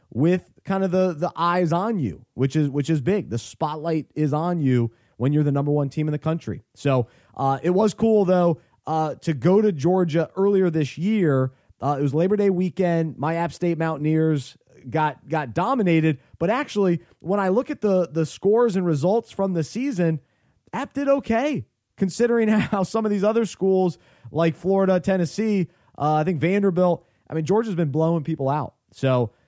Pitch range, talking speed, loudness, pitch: 150-190 Hz, 190 wpm, -22 LUFS, 165 Hz